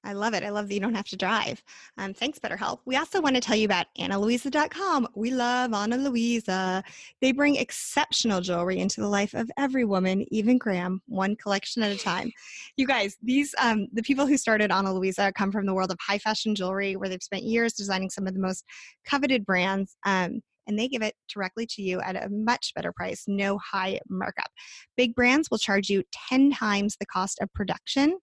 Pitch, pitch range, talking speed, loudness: 210 Hz, 195-250 Hz, 210 wpm, -26 LUFS